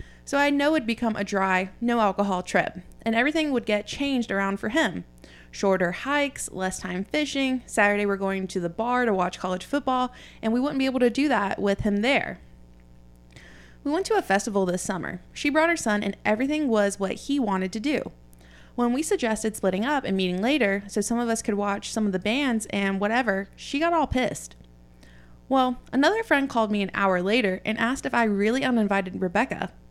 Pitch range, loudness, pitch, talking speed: 190-255 Hz, -25 LUFS, 210 Hz, 205 wpm